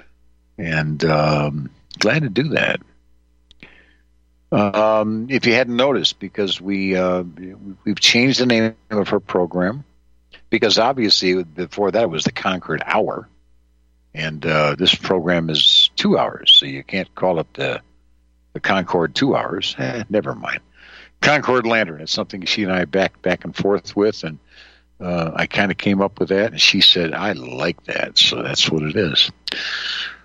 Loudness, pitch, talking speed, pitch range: -17 LUFS, 90 Hz, 165 wpm, 60-100 Hz